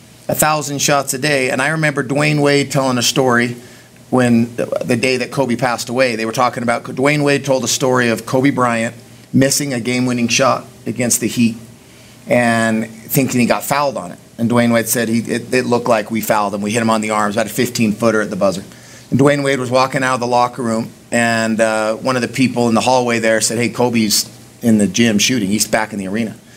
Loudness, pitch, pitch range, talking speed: -15 LUFS, 120 Hz, 115-130 Hz, 235 wpm